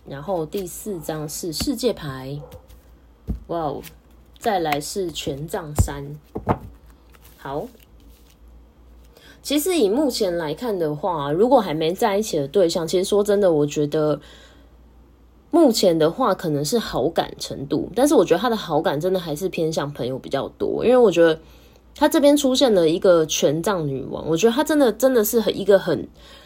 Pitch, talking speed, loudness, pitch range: 160 Hz, 240 characters per minute, -21 LUFS, 140-210 Hz